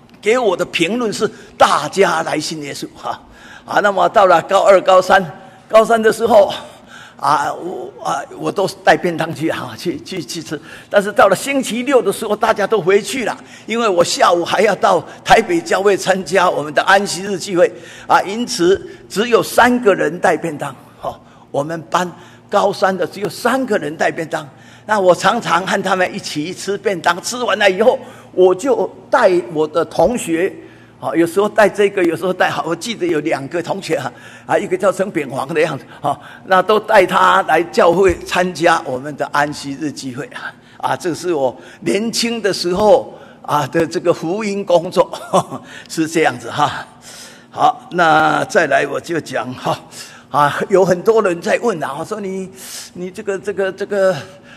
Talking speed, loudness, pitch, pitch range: 255 characters per minute, -16 LUFS, 190 Hz, 165-215 Hz